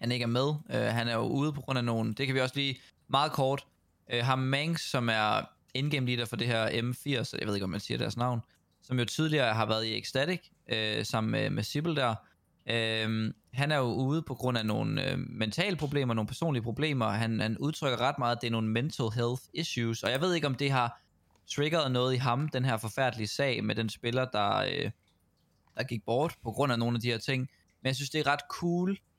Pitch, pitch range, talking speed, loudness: 125 Hz, 115-140 Hz, 240 wpm, -31 LUFS